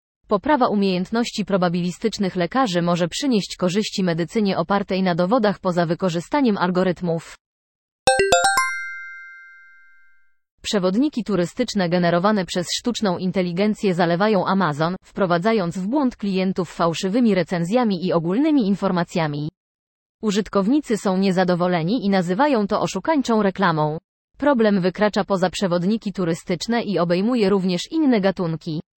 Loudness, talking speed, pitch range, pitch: -20 LUFS, 100 wpm, 175-215 Hz, 190 Hz